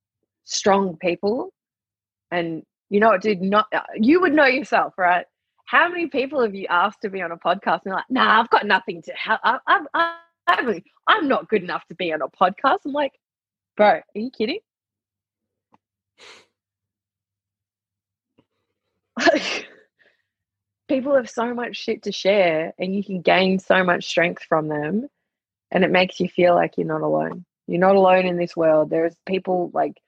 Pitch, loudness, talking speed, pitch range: 185 Hz, -20 LUFS, 170 wpm, 145-220 Hz